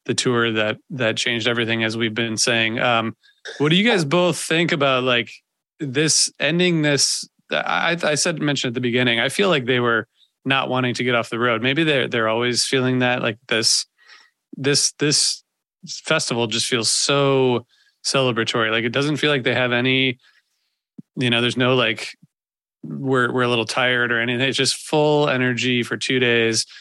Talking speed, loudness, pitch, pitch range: 185 wpm, -19 LUFS, 125 Hz, 120-145 Hz